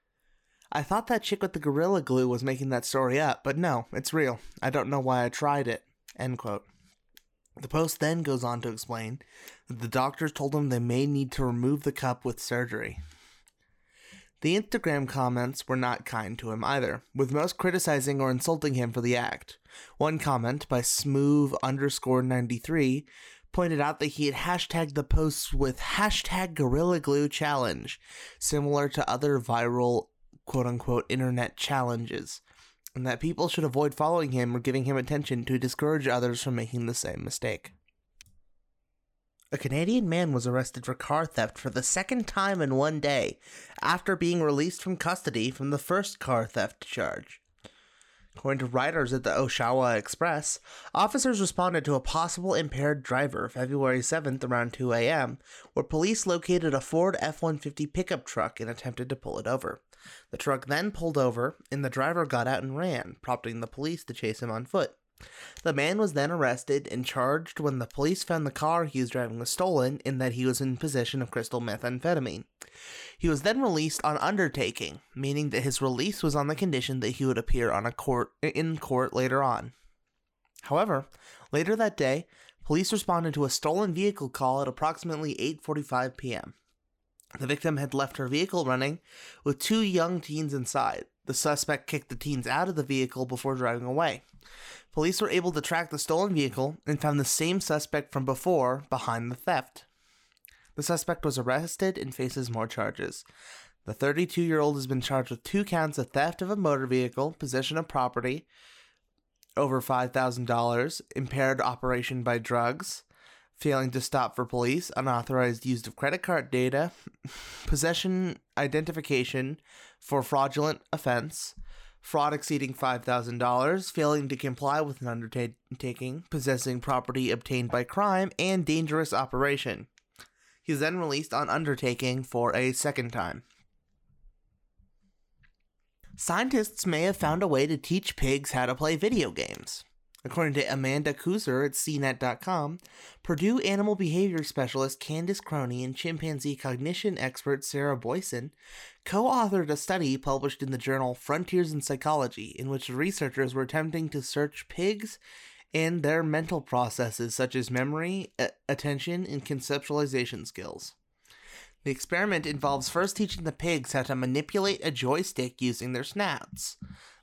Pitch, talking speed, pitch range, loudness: 140 Hz, 165 wpm, 125-160 Hz, -29 LUFS